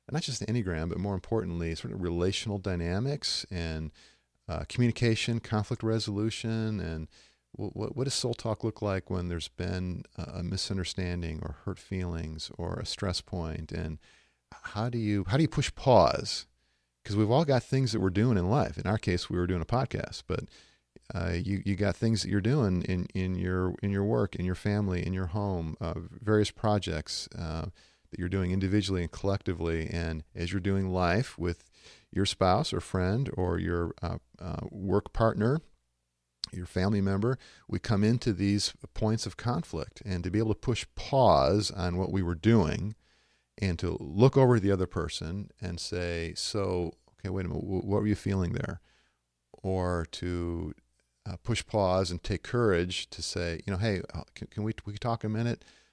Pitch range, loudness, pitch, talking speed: 85-110 Hz, -31 LUFS, 95 Hz, 185 wpm